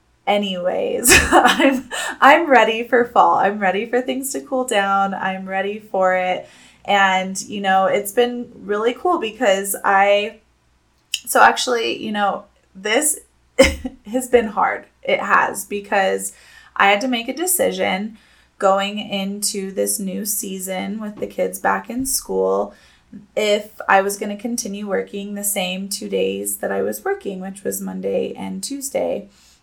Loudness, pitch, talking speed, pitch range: -18 LUFS, 205 Hz, 150 wpm, 190-240 Hz